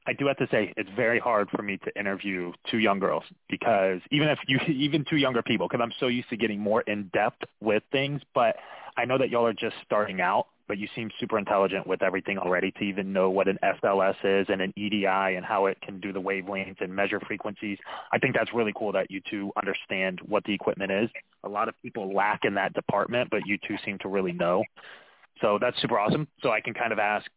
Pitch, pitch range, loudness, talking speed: 105 Hz, 95-120 Hz, -27 LUFS, 240 wpm